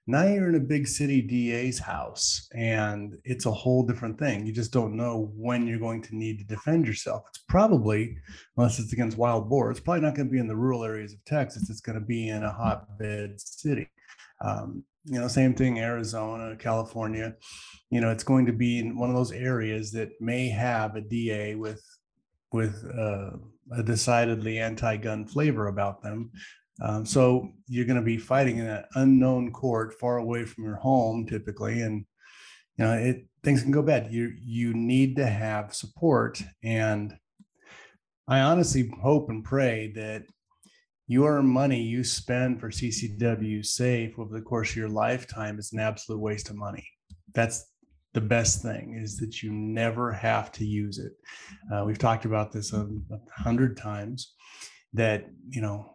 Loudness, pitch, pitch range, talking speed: -27 LUFS, 115 Hz, 110-125 Hz, 180 wpm